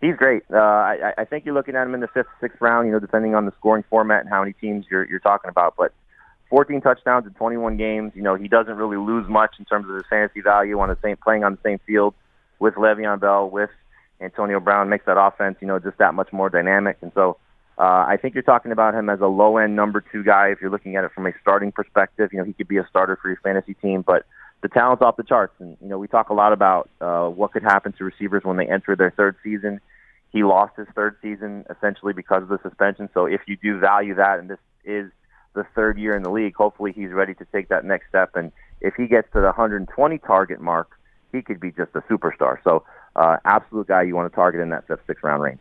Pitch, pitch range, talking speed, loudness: 100 Hz, 95-110 Hz, 255 wpm, -20 LUFS